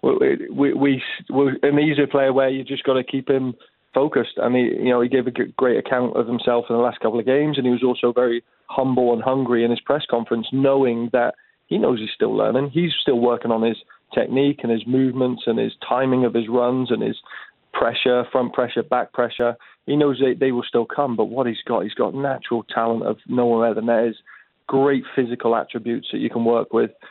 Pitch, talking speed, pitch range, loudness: 125 Hz, 225 wpm, 120-135 Hz, -20 LUFS